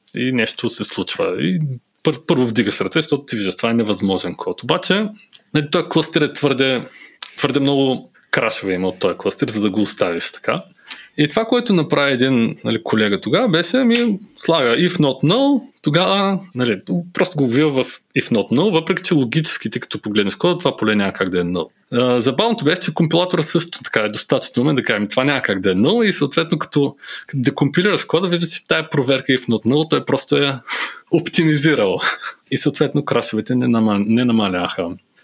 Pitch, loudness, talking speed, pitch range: 150 Hz, -18 LUFS, 185 wpm, 125-175 Hz